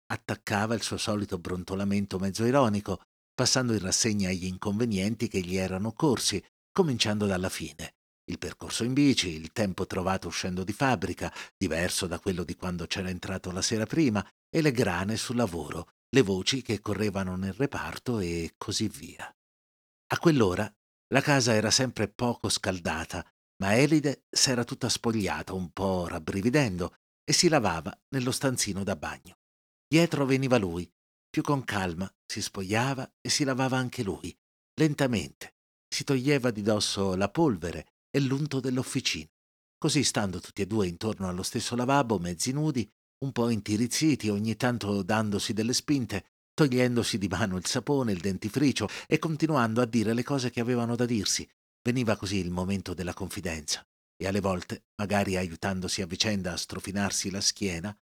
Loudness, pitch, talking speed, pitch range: -28 LUFS, 105 Hz, 155 wpm, 95-125 Hz